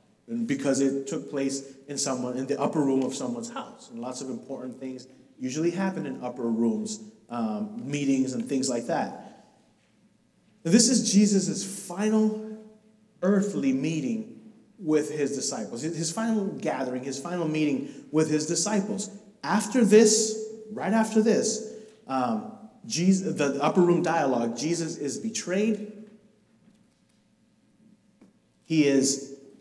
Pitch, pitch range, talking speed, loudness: 185 Hz, 140-220 Hz, 130 wpm, -26 LUFS